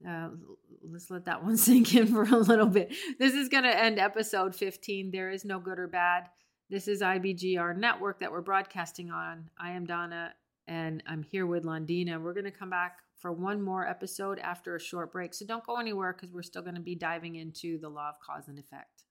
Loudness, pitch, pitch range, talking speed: -30 LUFS, 180 Hz, 170-200 Hz, 225 wpm